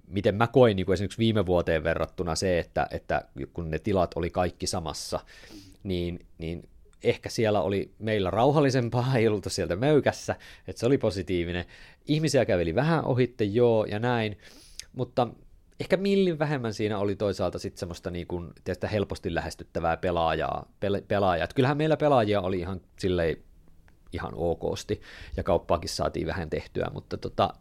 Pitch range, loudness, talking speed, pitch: 85-115 Hz, -27 LUFS, 150 wpm, 95 Hz